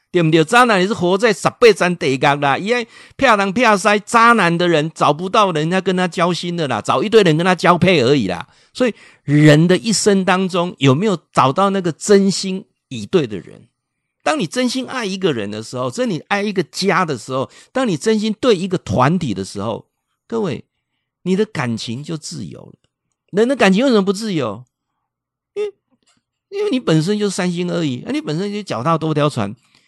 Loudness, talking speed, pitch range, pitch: -16 LUFS, 285 characters per minute, 150-210 Hz, 180 Hz